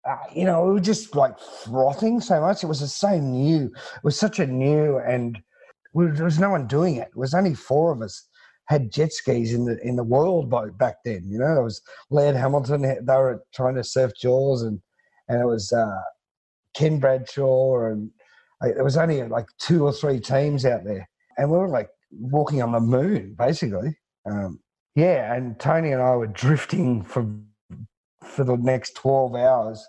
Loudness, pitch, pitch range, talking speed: -22 LUFS, 135 Hz, 120-155 Hz, 200 wpm